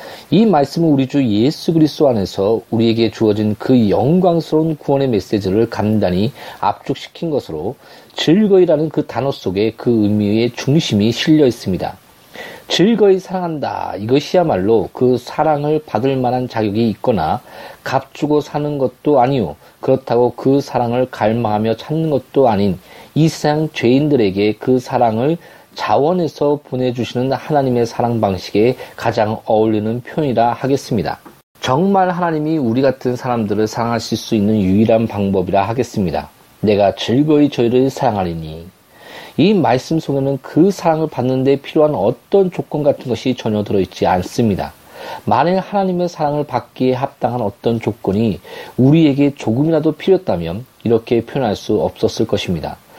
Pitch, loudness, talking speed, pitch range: 130 Hz, -16 LUFS, 335 characters per minute, 115-150 Hz